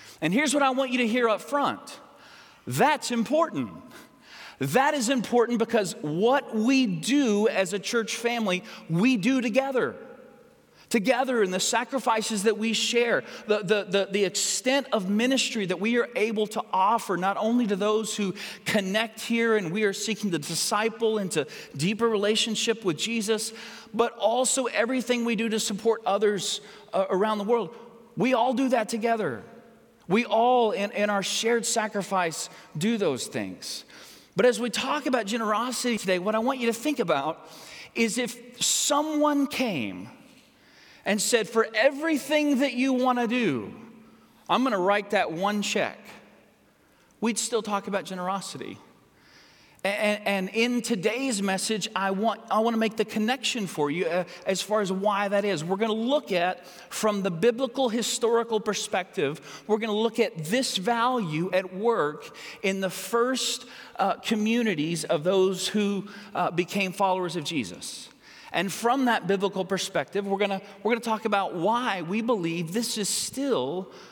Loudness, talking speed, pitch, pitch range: -26 LUFS, 165 wpm, 220 Hz, 200-240 Hz